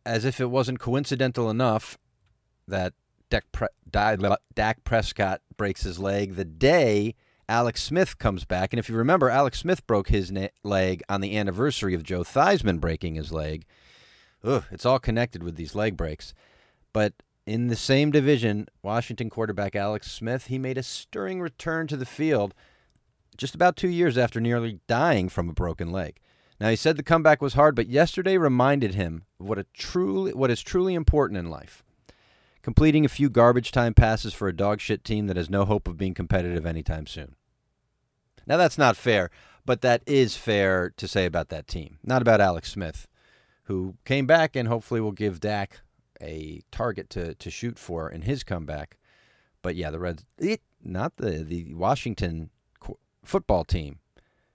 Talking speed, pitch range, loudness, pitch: 175 wpm, 90-130 Hz, -25 LUFS, 105 Hz